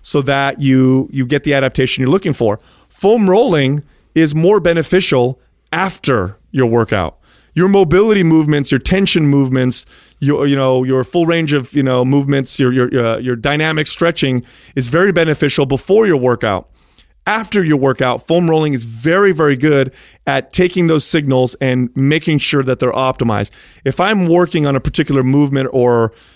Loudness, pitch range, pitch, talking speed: -14 LUFS, 130-165 Hz, 140 Hz, 165 wpm